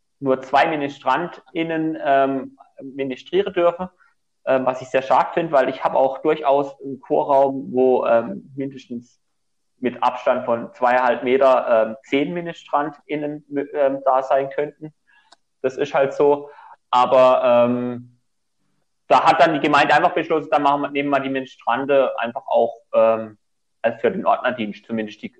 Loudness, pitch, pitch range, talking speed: -19 LUFS, 135 Hz, 125-145 Hz, 150 wpm